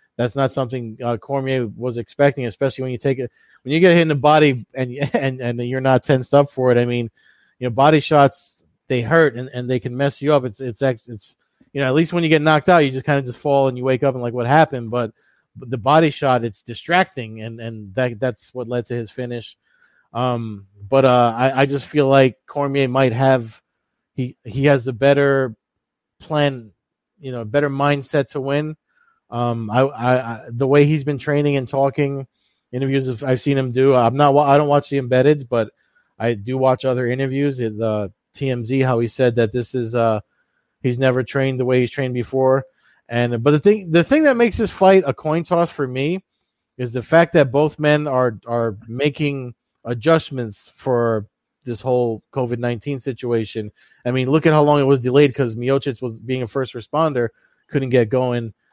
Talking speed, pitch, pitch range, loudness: 210 wpm, 130 Hz, 120-145 Hz, -18 LUFS